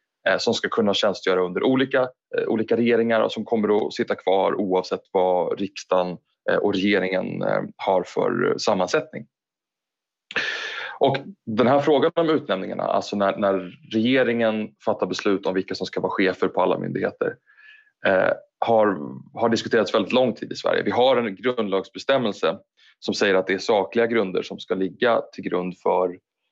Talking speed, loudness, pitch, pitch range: 155 wpm, -22 LUFS, 110 Hz, 95-135 Hz